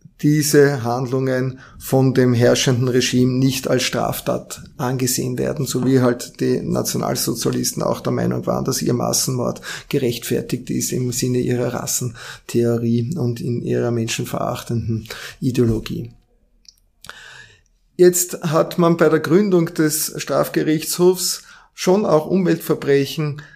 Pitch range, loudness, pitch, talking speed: 120-155 Hz, -19 LUFS, 130 Hz, 115 wpm